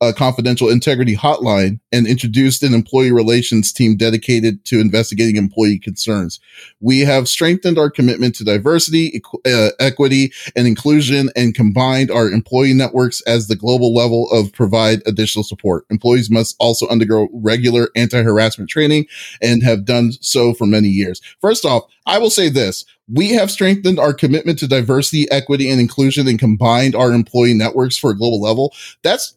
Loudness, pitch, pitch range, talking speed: -14 LUFS, 120 Hz, 110-135 Hz, 165 wpm